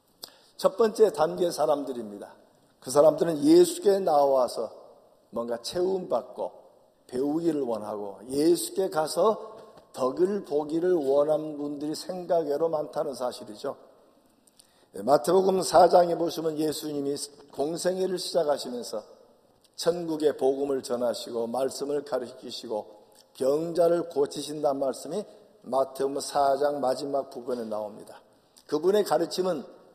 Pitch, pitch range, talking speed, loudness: 155 Hz, 140-180 Hz, 270 characters per minute, -27 LUFS